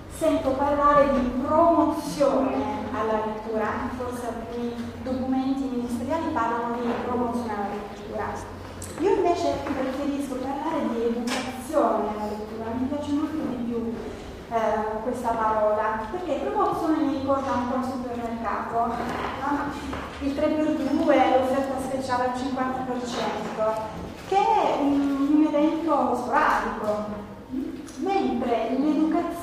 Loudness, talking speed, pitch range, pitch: -25 LUFS, 110 wpm, 230-290 Hz, 260 Hz